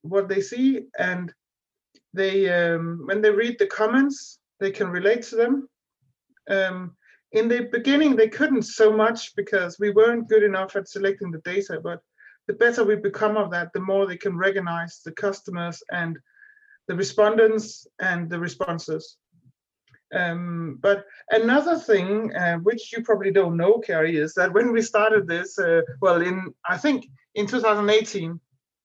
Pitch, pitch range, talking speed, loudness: 200 Hz, 180-225 Hz, 160 wpm, -22 LUFS